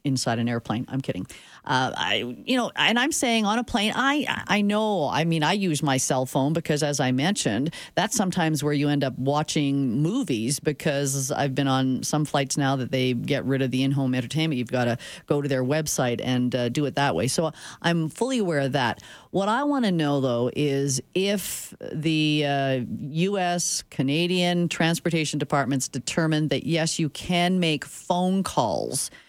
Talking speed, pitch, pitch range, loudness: 195 wpm, 150 Hz, 135-175 Hz, -24 LUFS